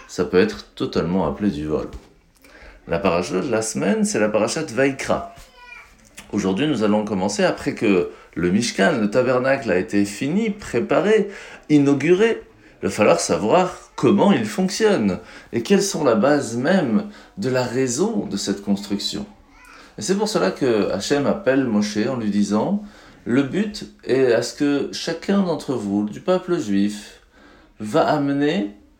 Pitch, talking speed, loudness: 130 Hz, 155 wpm, -20 LUFS